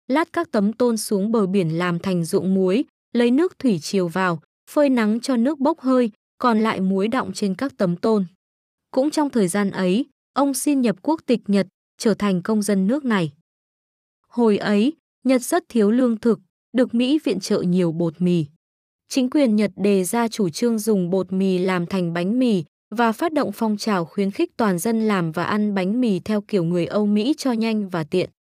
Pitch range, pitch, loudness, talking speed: 190-250 Hz, 210 Hz, -21 LUFS, 205 wpm